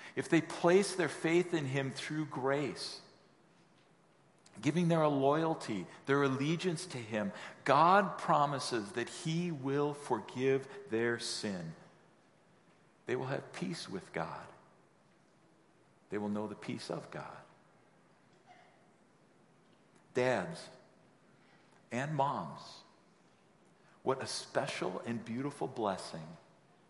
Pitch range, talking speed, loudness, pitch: 125-165 Hz, 105 wpm, -35 LUFS, 145 Hz